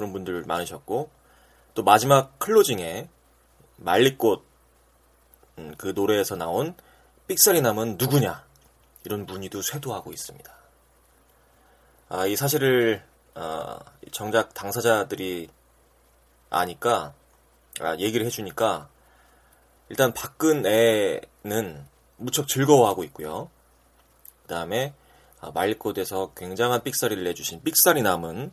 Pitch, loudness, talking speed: 90 Hz, -24 LUFS, 235 characters per minute